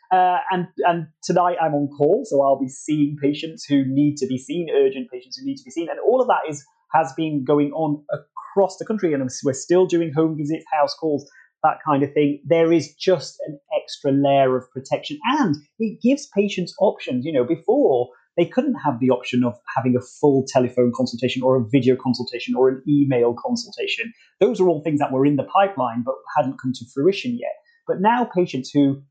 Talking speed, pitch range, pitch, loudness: 210 wpm, 135-185 Hz, 150 Hz, -21 LUFS